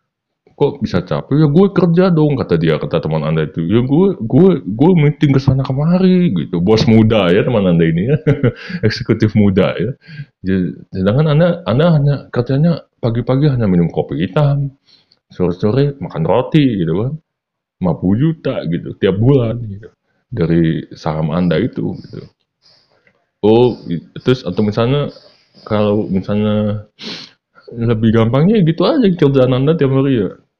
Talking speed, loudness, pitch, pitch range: 145 wpm, -14 LUFS, 130 Hz, 105-150 Hz